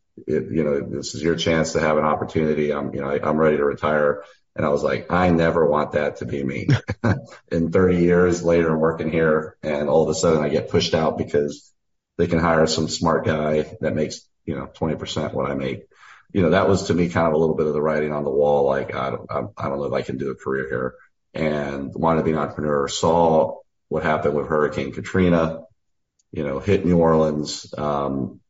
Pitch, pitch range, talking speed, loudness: 80 Hz, 75-85 Hz, 230 wpm, -21 LUFS